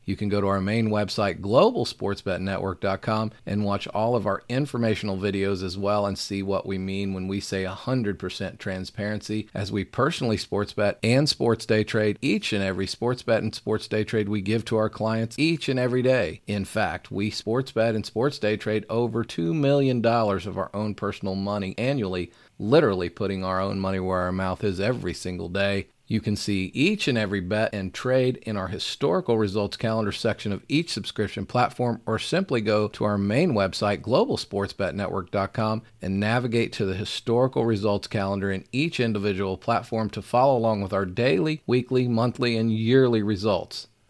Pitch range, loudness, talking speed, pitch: 100-115 Hz, -25 LUFS, 180 wpm, 105 Hz